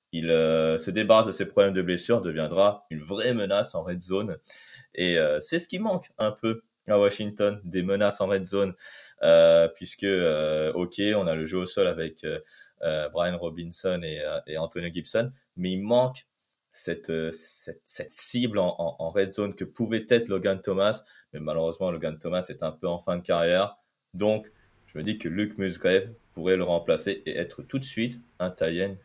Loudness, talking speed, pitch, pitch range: -26 LUFS, 200 wpm, 95 Hz, 85-110 Hz